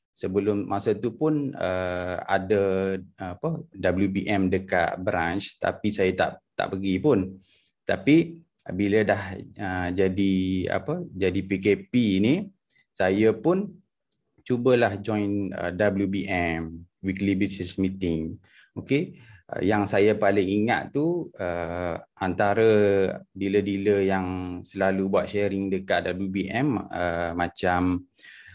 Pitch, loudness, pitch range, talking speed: 95 Hz, -25 LUFS, 95-105 Hz, 110 wpm